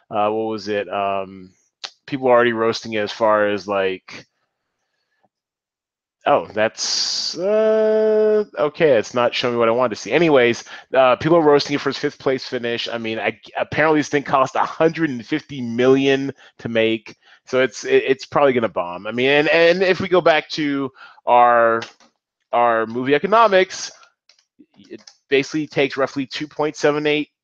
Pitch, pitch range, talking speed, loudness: 135 Hz, 115-155 Hz, 175 wpm, -18 LUFS